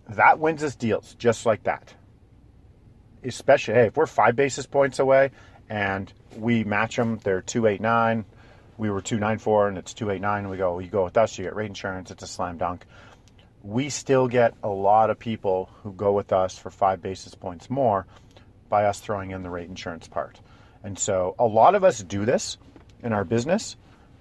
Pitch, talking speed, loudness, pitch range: 105 Hz, 190 wpm, -24 LUFS, 95-115 Hz